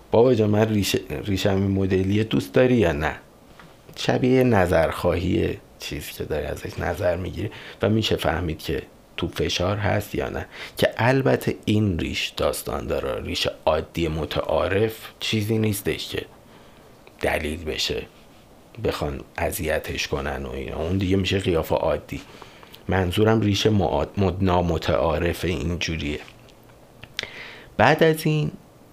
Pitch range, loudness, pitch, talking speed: 85-110 Hz, -23 LUFS, 95 Hz, 125 wpm